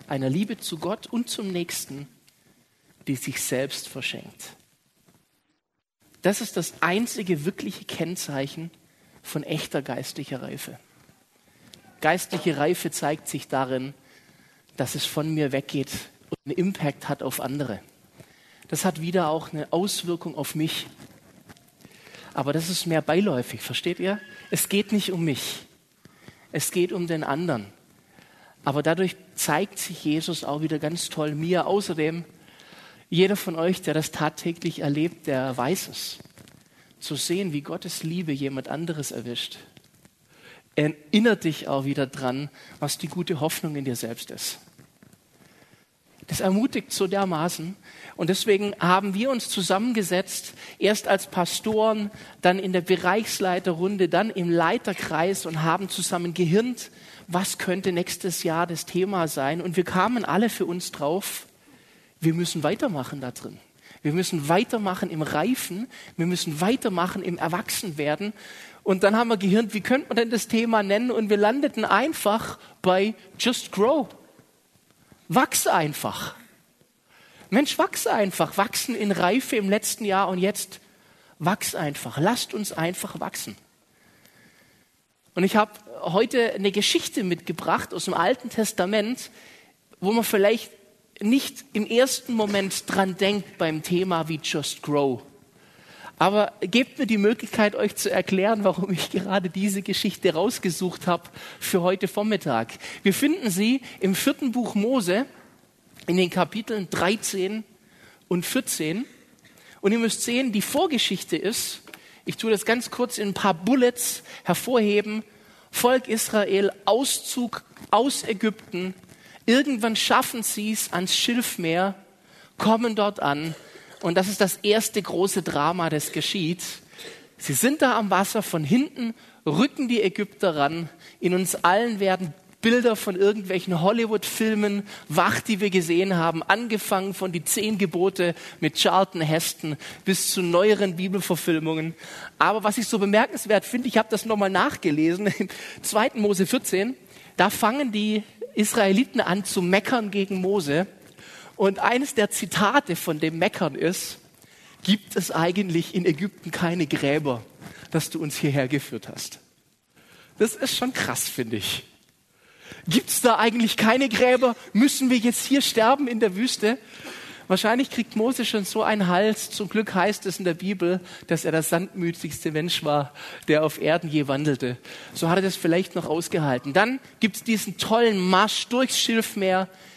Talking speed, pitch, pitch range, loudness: 145 wpm, 190 Hz, 165-215 Hz, -24 LUFS